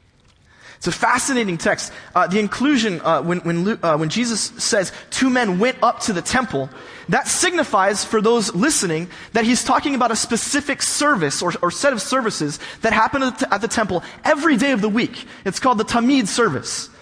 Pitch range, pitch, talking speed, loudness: 195-260 Hz, 230 Hz, 185 wpm, -19 LUFS